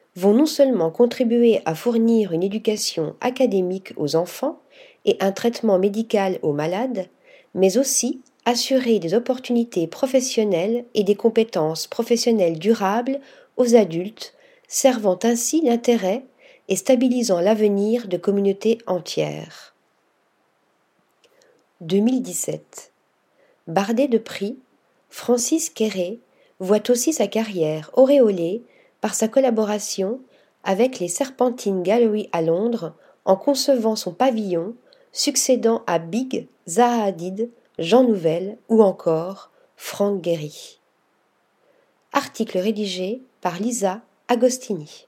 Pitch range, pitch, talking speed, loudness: 190-255 Hz, 225 Hz, 105 wpm, -21 LUFS